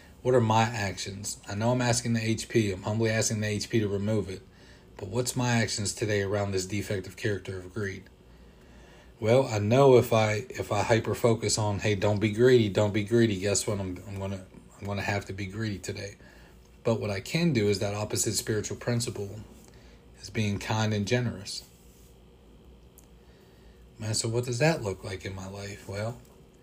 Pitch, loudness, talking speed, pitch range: 105 Hz, -28 LUFS, 190 wpm, 95-115 Hz